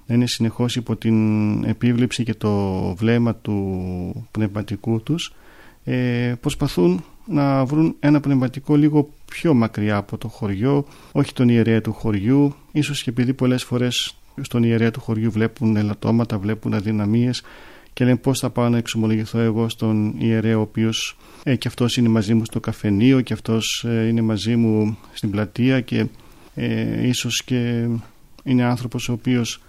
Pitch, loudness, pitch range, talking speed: 115 Hz, -20 LUFS, 110-125 Hz, 155 wpm